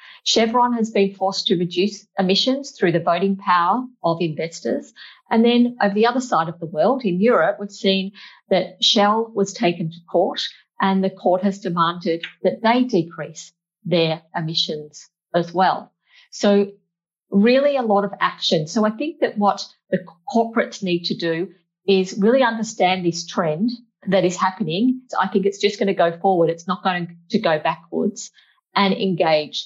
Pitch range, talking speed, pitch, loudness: 175-215 Hz, 170 wpm, 195 Hz, -20 LUFS